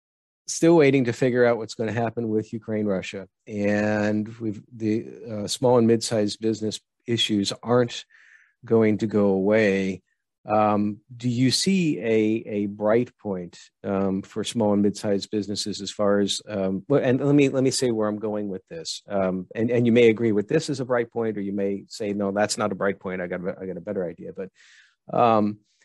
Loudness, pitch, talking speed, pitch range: -24 LUFS, 110 Hz, 200 wpm, 100-120 Hz